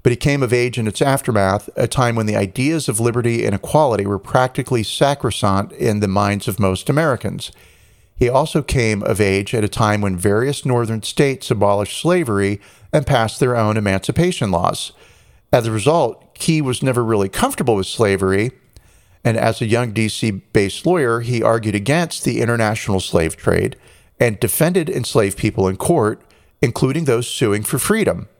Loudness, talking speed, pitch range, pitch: -18 LUFS, 170 wpm, 100-125 Hz, 110 Hz